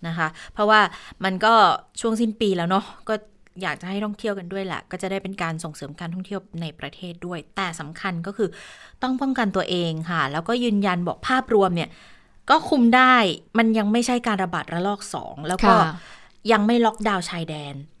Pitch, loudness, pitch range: 195 Hz, -22 LUFS, 170-220 Hz